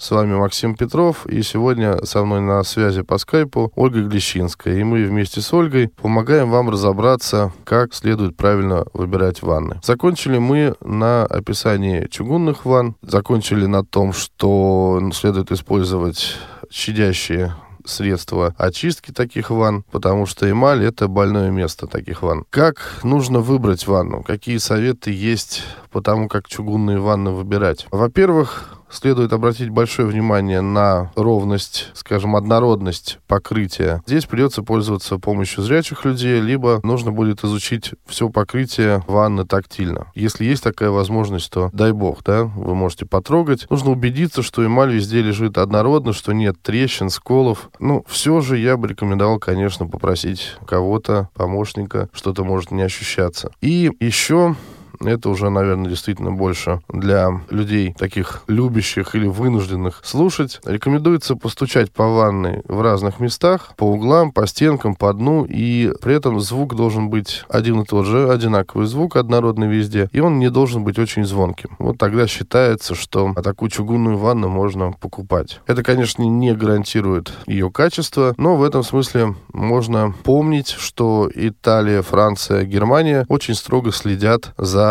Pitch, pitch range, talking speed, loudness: 105 Hz, 100-120 Hz, 145 wpm, -17 LUFS